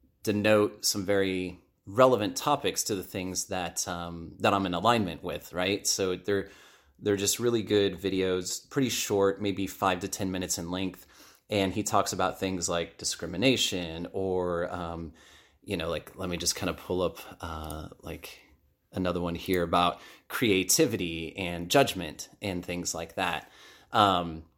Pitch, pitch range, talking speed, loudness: 95 Hz, 85-100 Hz, 160 wpm, -29 LUFS